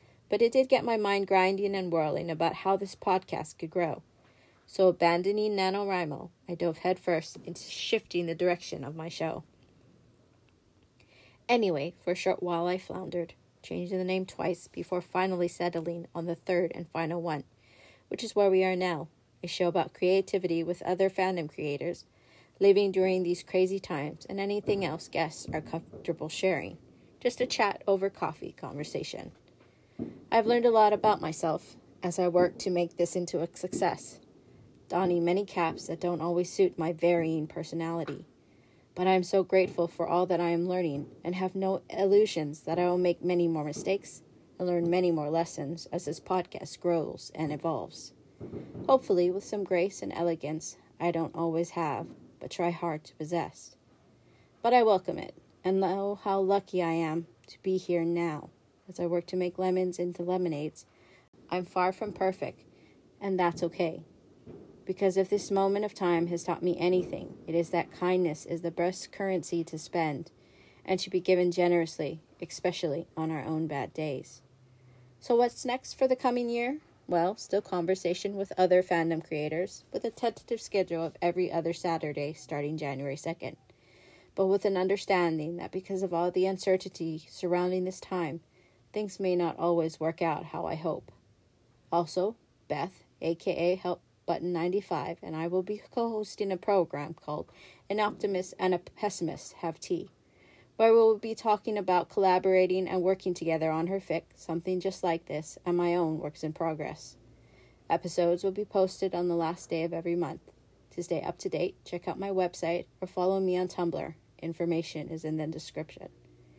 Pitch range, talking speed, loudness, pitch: 165-190 Hz, 170 wpm, -30 LUFS, 175 Hz